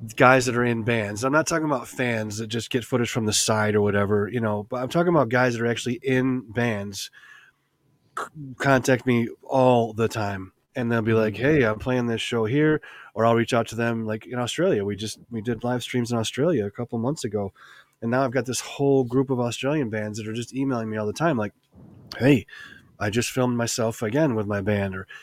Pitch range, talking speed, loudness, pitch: 110-130 Hz, 230 wpm, -24 LUFS, 120 Hz